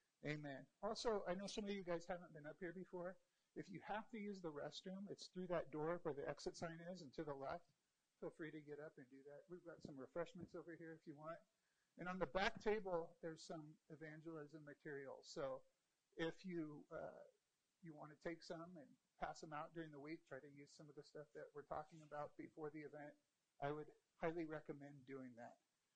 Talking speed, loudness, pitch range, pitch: 220 wpm, -52 LUFS, 150-180 Hz, 165 Hz